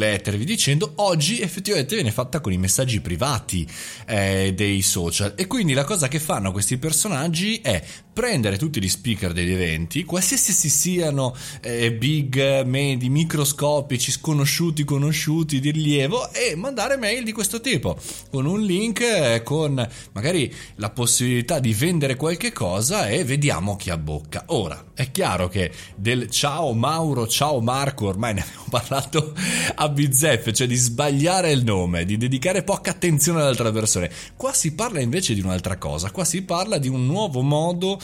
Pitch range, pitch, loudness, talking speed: 110-165 Hz, 135 Hz, -21 LUFS, 160 wpm